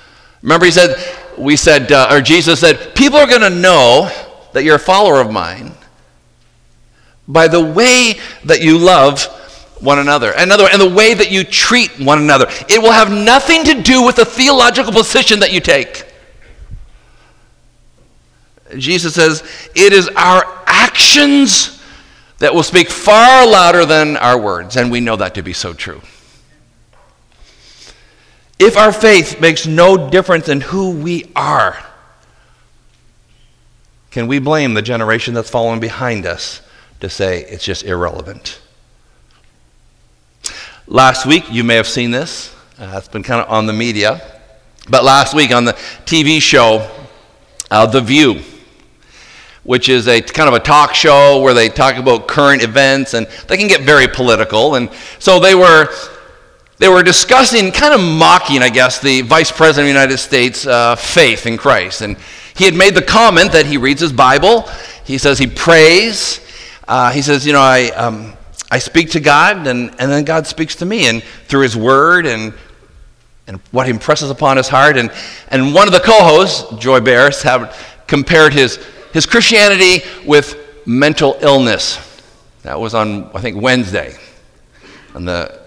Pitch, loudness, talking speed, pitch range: 145 Hz, -9 LUFS, 160 wpm, 120-180 Hz